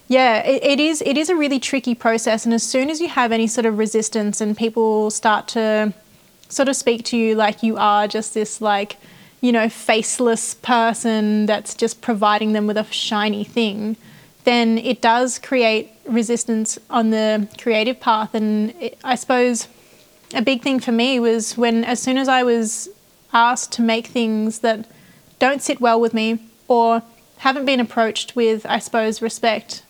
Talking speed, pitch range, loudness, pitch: 180 wpm, 220-245 Hz, -18 LUFS, 230 Hz